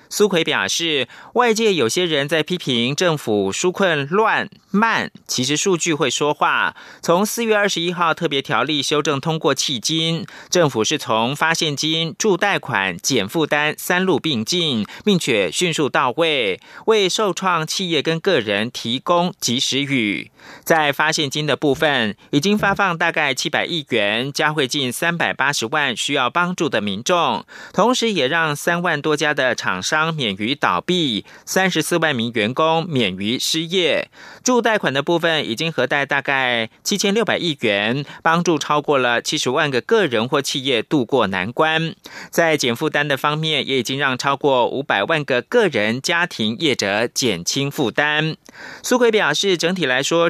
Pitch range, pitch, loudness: 140-180 Hz, 155 Hz, -18 LUFS